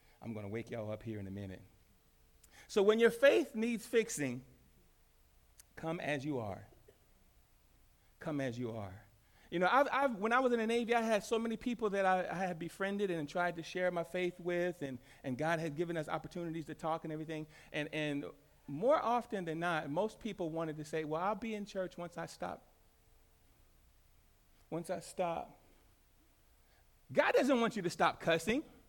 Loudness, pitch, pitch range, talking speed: -36 LUFS, 165 Hz, 120-200 Hz, 190 wpm